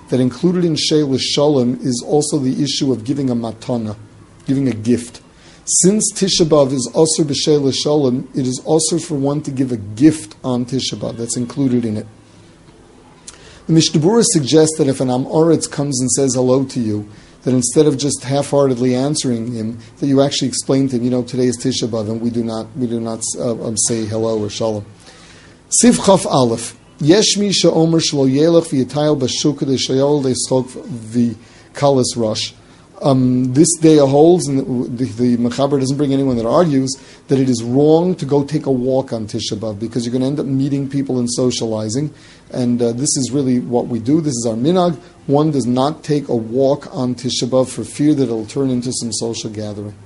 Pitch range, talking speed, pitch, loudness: 120-145 Hz, 190 wpm, 130 Hz, -16 LUFS